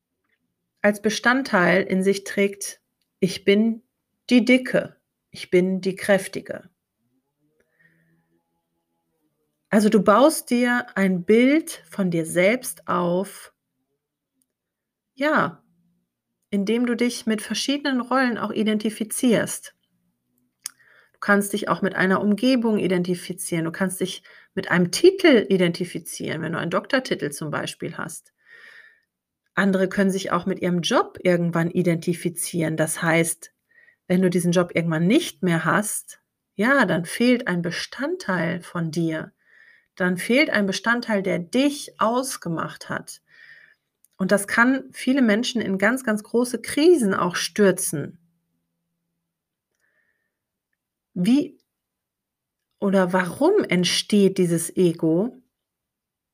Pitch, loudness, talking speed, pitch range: 195 Hz, -22 LUFS, 115 wpm, 175-240 Hz